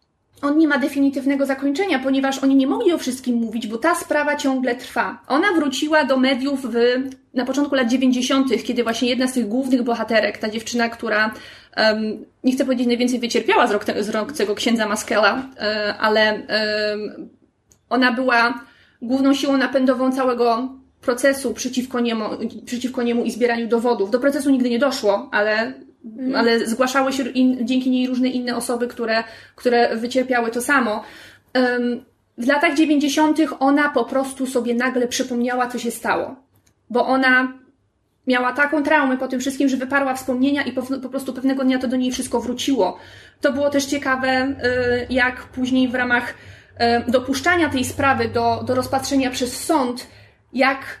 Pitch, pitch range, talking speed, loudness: 255 Hz, 235-270 Hz, 160 wpm, -20 LUFS